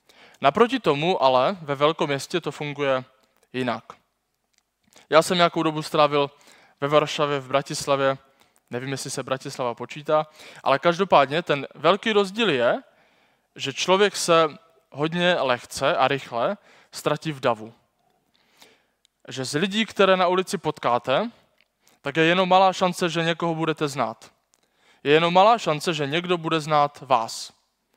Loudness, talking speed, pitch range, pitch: -22 LUFS, 135 wpm, 135-175 Hz, 155 Hz